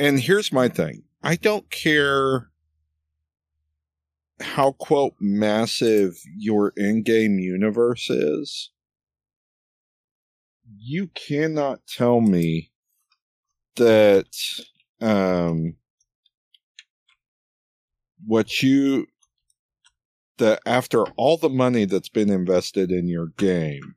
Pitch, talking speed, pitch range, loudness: 105 Hz, 85 wpm, 80-130 Hz, -21 LUFS